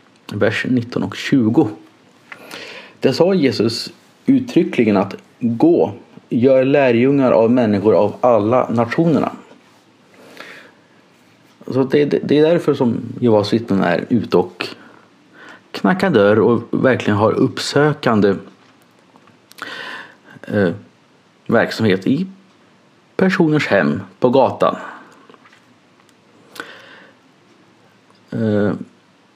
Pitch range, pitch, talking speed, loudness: 115-155 Hz, 135 Hz, 90 wpm, -16 LUFS